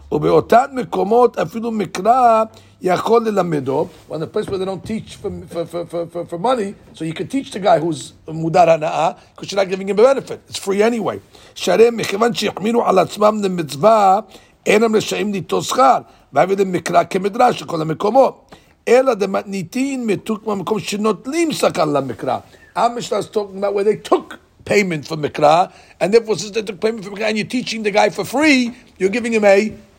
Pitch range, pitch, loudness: 185-225 Hz, 205 Hz, -17 LUFS